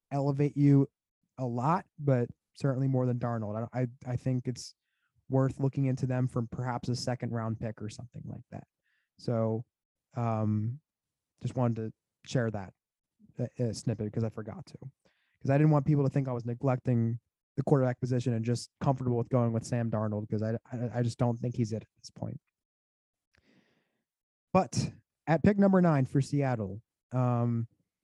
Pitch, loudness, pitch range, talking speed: 125 Hz, -31 LUFS, 115-135 Hz, 175 wpm